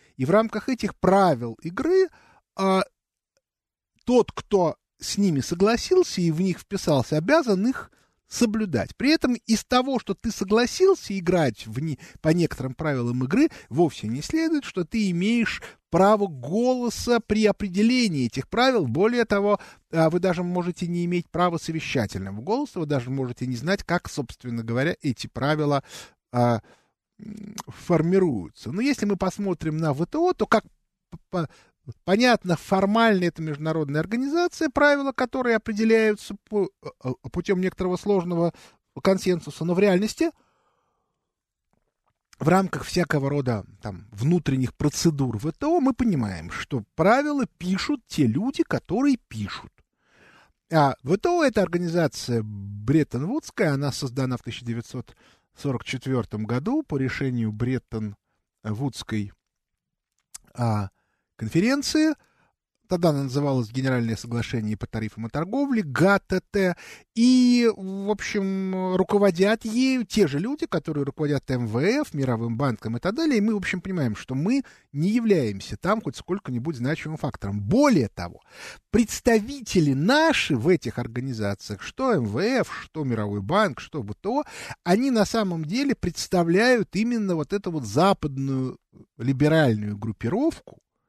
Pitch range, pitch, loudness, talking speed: 135-215 Hz, 175 Hz, -24 LUFS, 130 wpm